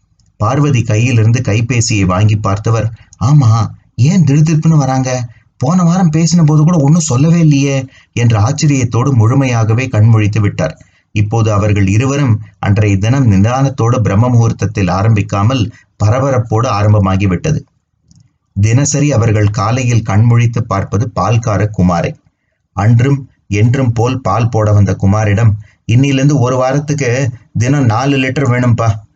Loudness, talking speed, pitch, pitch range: -12 LUFS, 115 wpm, 115 Hz, 105-130 Hz